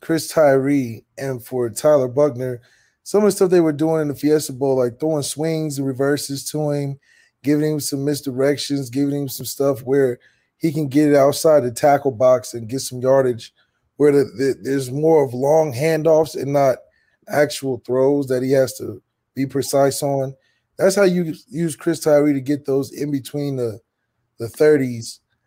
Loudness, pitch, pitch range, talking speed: -19 LUFS, 140 Hz, 130-150 Hz, 185 wpm